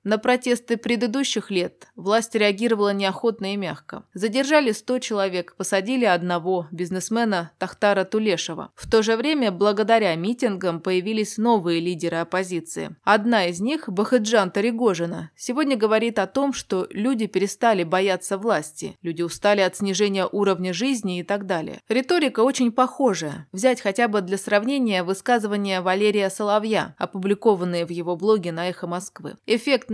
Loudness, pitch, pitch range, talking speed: -22 LUFS, 205 Hz, 185-230 Hz, 140 wpm